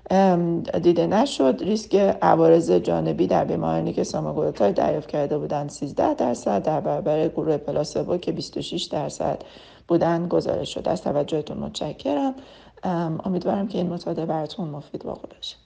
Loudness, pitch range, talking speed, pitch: -23 LUFS, 150-190 Hz, 135 wpm, 170 Hz